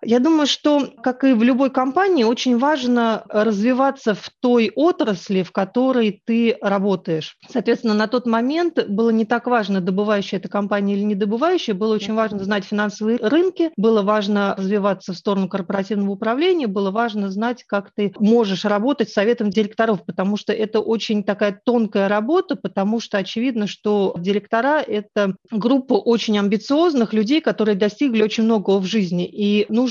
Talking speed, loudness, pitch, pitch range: 160 wpm, -19 LUFS, 220 Hz, 205-240 Hz